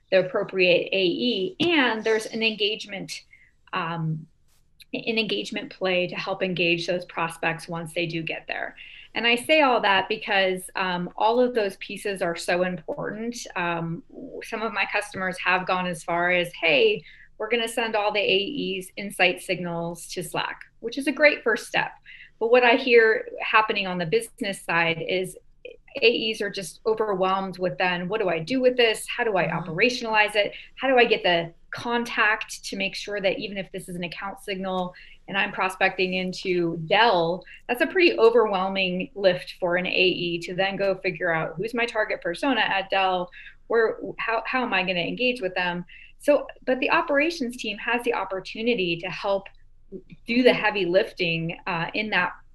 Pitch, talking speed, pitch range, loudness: 195 Hz, 180 wpm, 180-230 Hz, -24 LUFS